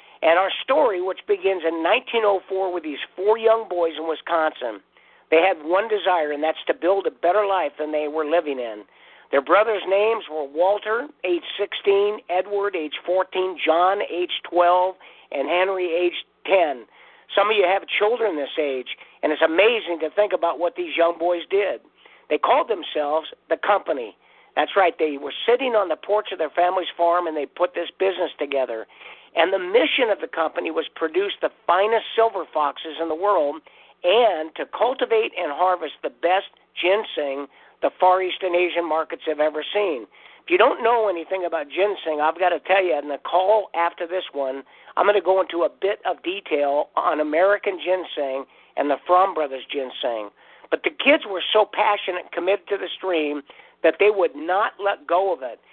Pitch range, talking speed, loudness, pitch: 160-205 Hz, 185 wpm, -22 LUFS, 180 Hz